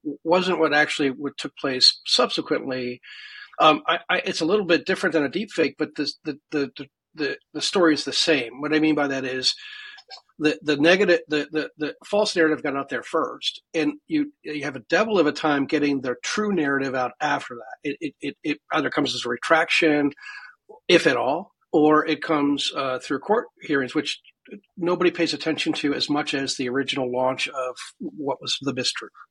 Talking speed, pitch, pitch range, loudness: 200 wpm, 155 Hz, 140-180 Hz, -23 LUFS